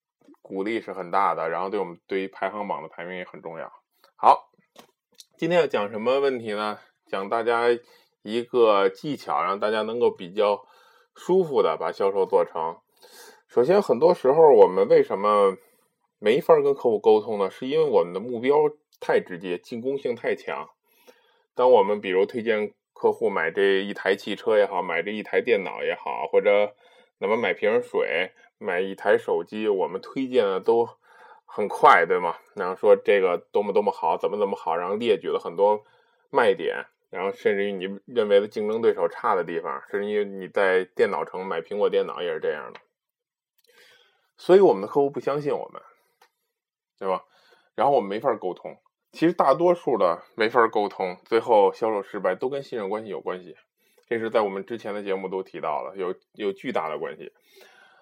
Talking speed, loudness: 275 characters per minute, -24 LUFS